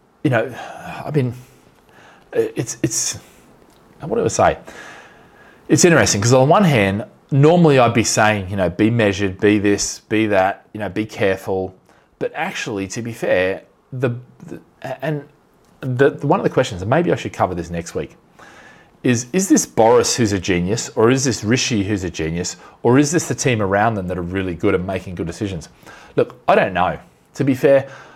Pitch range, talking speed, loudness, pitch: 95-140 Hz, 190 wpm, -18 LUFS, 110 Hz